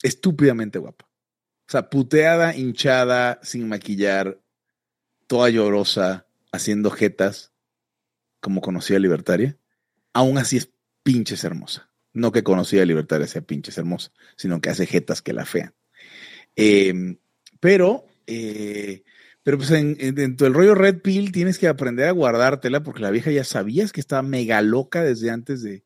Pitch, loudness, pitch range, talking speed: 120 Hz, -20 LUFS, 100-140 Hz, 145 wpm